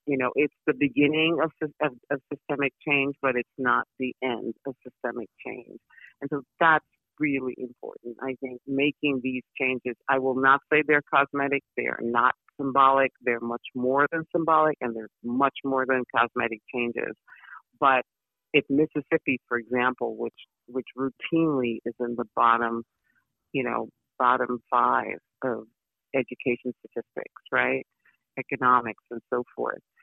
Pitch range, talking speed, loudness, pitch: 120-145 Hz, 145 wpm, -26 LUFS, 130 Hz